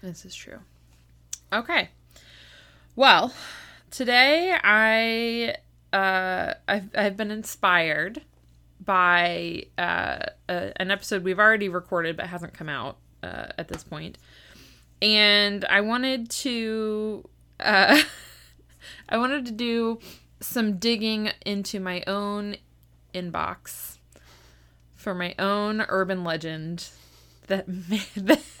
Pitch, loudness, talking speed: 195 Hz, -23 LUFS, 110 wpm